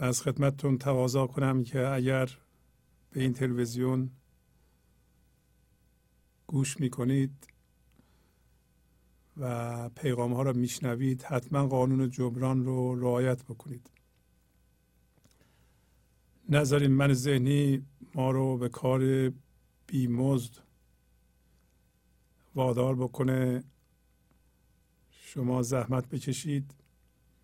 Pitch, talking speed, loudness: 125 Hz, 80 wpm, -30 LUFS